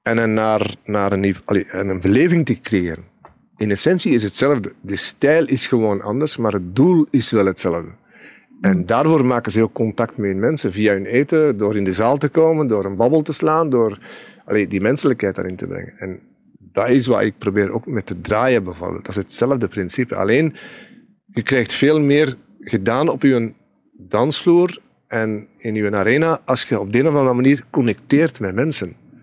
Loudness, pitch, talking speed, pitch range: -18 LUFS, 115 Hz, 190 wpm, 100-150 Hz